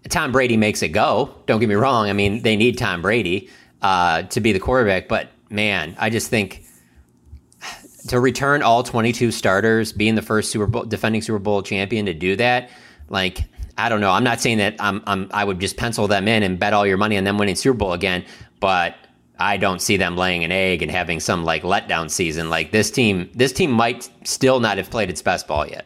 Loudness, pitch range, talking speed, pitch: -19 LUFS, 95-115 Hz, 225 wpm, 105 Hz